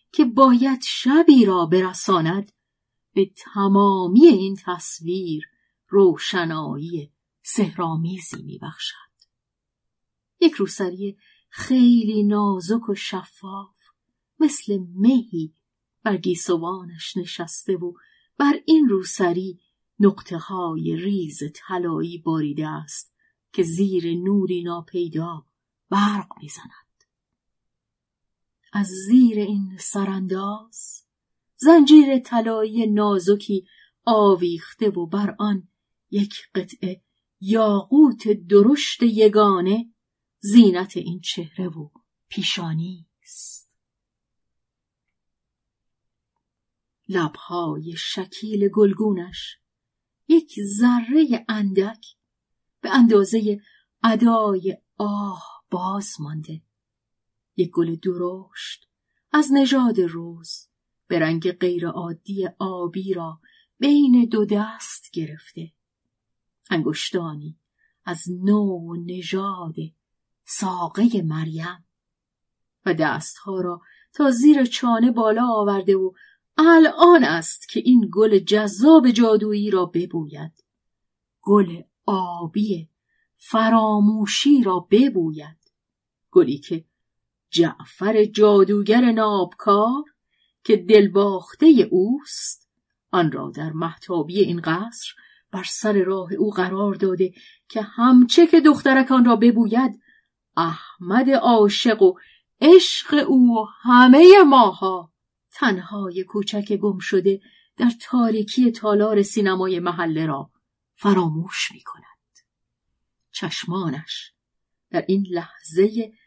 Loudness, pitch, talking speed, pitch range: -19 LUFS, 195 Hz, 85 wpm, 175-225 Hz